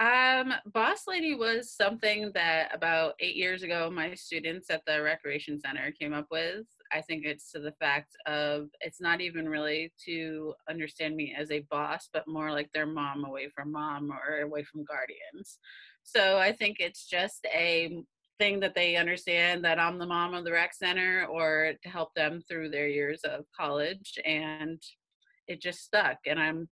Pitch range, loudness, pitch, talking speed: 150-180 Hz, -30 LUFS, 160 Hz, 180 wpm